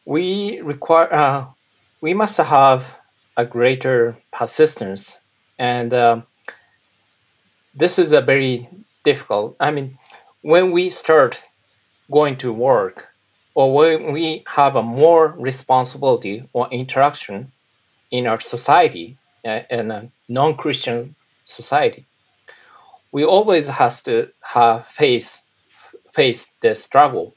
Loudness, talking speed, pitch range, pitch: -17 LUFS, 105 wpm, 120-165 Hz, 135 Hz